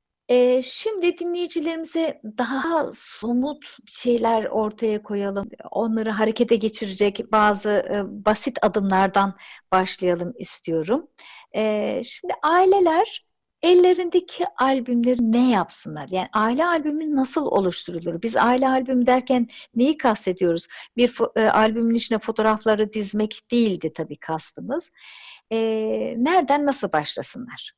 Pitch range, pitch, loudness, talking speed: 210-280 Hz, 230 Hz, -22 LUFS, 95 wpm